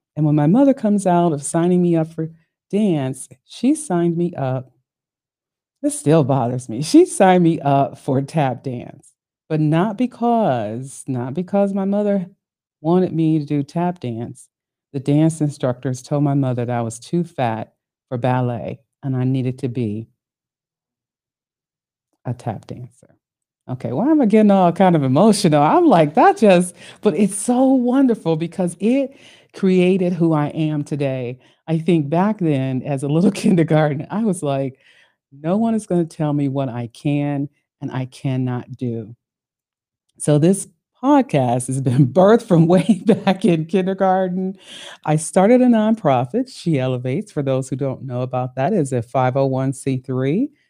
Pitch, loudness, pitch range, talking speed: 155 Hz, -18 LUFS, 130-190 Hz, 160 wpm